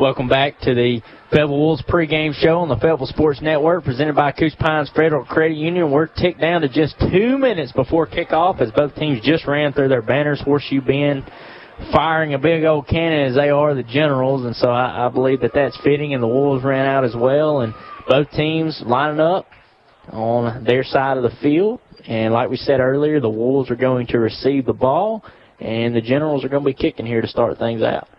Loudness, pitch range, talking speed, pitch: -18 LUFS, 130-155 Hz, 215 wpm, 140 Hz